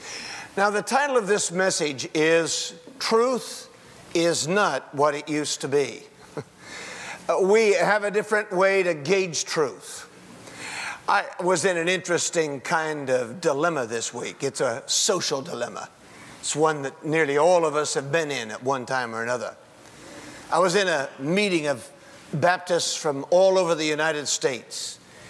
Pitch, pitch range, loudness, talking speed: 165 Hz, 140-185 Hz, -24 LUFS, 155 wpm